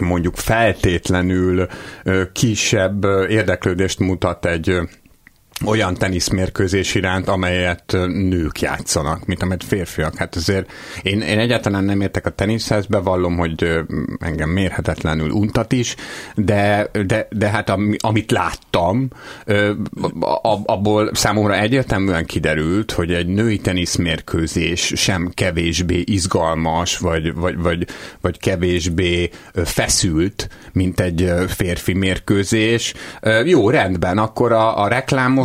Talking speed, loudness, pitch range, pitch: 105 wpm, -18 LUFS, 90-105 Hz, 95 Hz